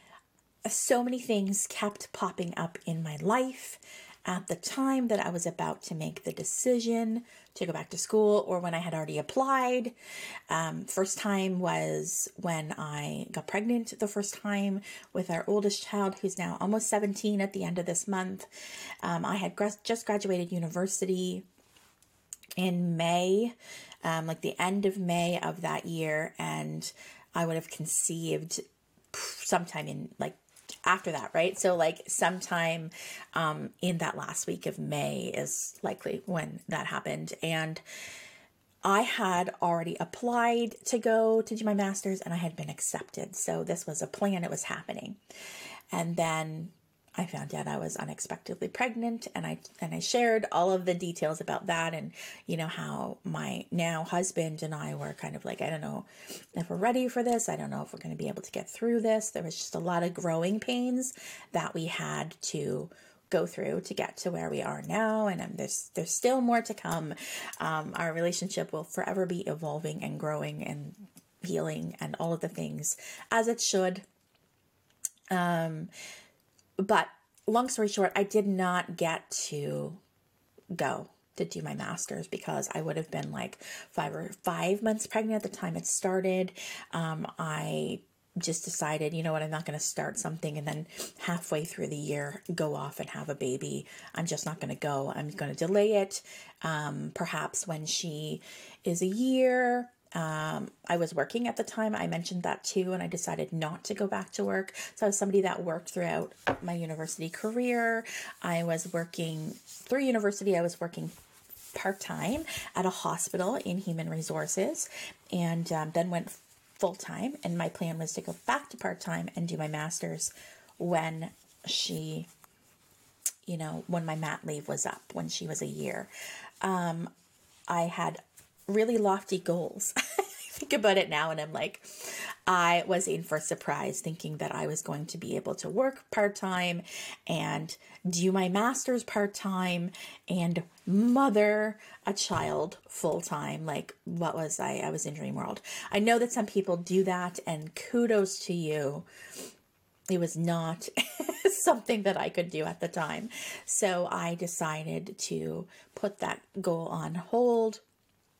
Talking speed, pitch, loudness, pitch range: 175 wpm, 180 Hz, -32 LUFS, 165-210 Hz